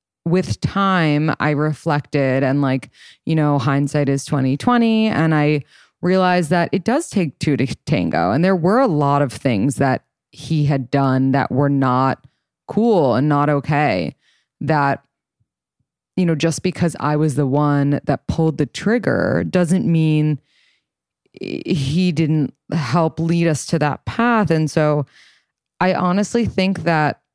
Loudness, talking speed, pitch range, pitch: -18 LUFS, 150 wpm, 140-180 Hz, 155 Hz